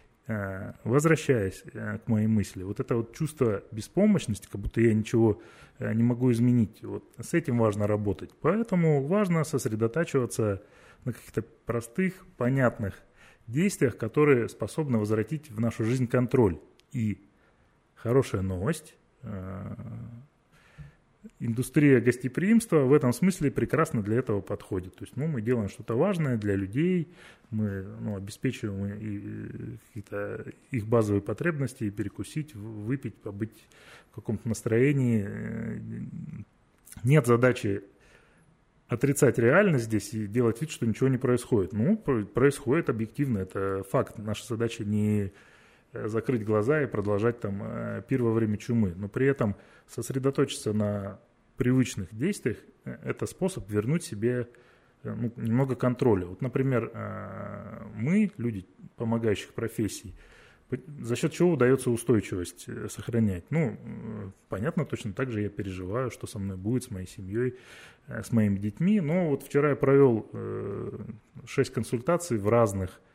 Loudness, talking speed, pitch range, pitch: -28 LUFS, 125 wpm, 105-135 Hz, 115 Hz